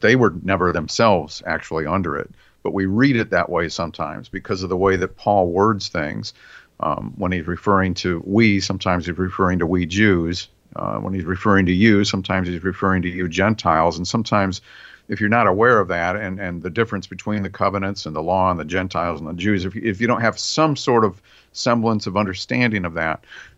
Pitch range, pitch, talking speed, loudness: 90-105 Hz, 95 Hz, 210 wpm, -20 LUFS